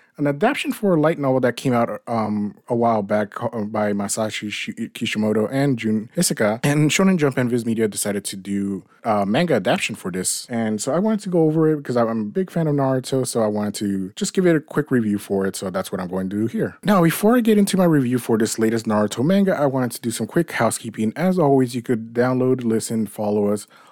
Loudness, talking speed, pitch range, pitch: -20 LUFS, 240 wpm, 105-150 Hz, 120 Hz